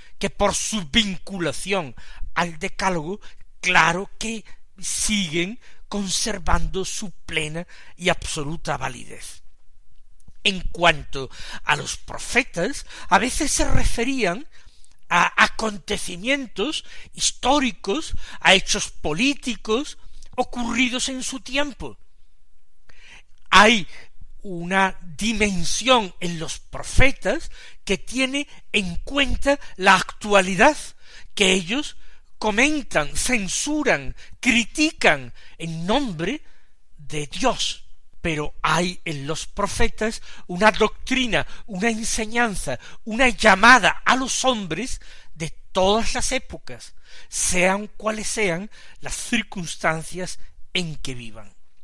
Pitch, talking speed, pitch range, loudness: 200 Hz, 95 wpm, 170-240 Hz, -21 LUFS